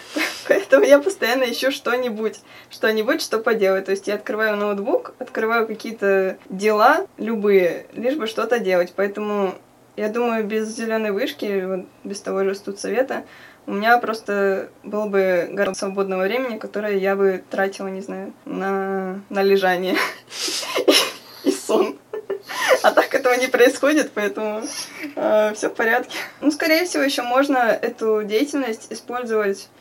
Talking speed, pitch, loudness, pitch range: 145 wpm, 215 Hz, -20 LUFS, 195-250 Hz